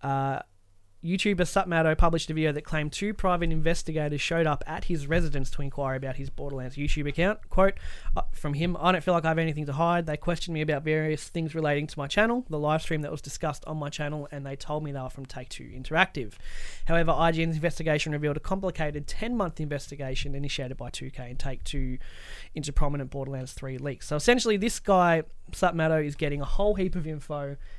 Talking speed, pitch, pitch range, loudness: 210 wpm, 150 Hz, 140-165 Hz, -28 LUFS